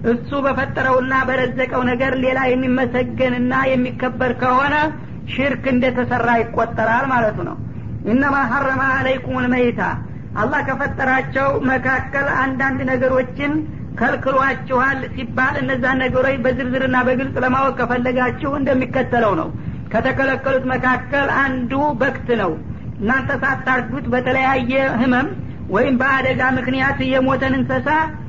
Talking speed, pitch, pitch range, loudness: 100 wpm, 260 Hz, 255-270 Hz, -18 LUFS